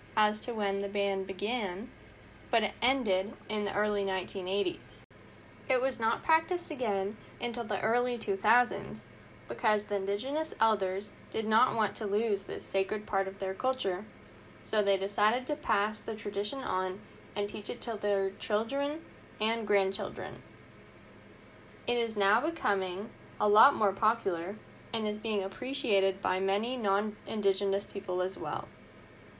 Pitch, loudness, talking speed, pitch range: 205 Hz, -31 LUFS, 145 wpm, 195-225 Hz